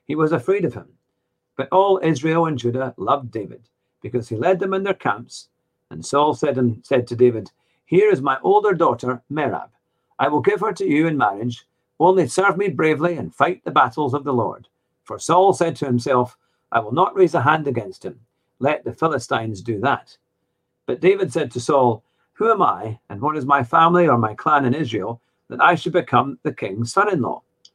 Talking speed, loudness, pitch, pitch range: 205 wpm, -19 LUFS, 150 Hz, 125-175 Hz